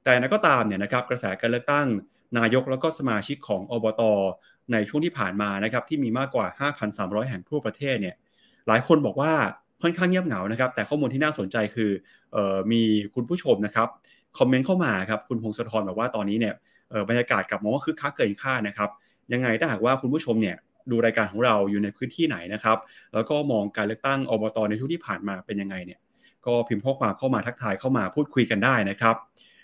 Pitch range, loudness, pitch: 105-135 Hz, -25 LUFS, 115 Hz